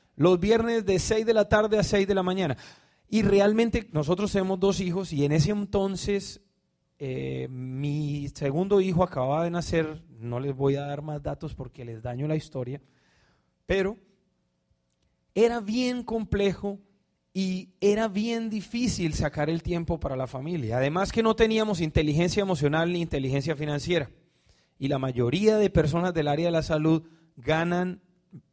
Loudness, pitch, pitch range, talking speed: -26 LUFS, 175 Hz, 145-200 Hz, 160 wpm